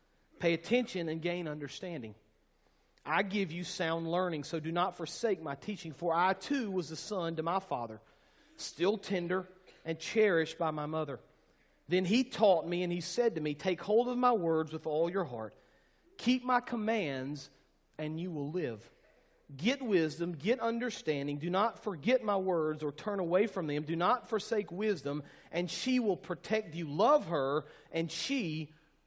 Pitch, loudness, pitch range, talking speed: 175 Hz, -34 LUFS, 155-210 Hz, 175 wpm